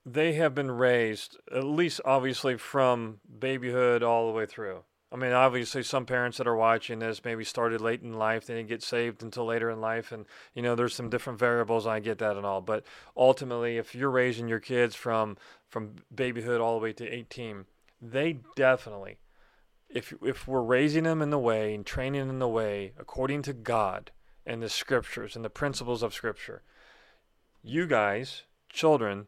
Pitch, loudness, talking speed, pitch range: 120 Hz, -29 LUFS, 190 wpm, 115-130 Hz